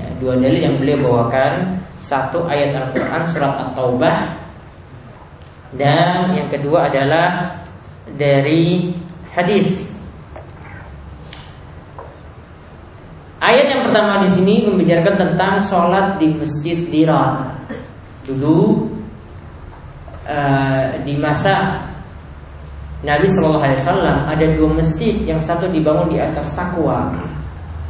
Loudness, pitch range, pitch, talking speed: -16 LUFS, 130-175 Hz, 150 Hz, 95 wpm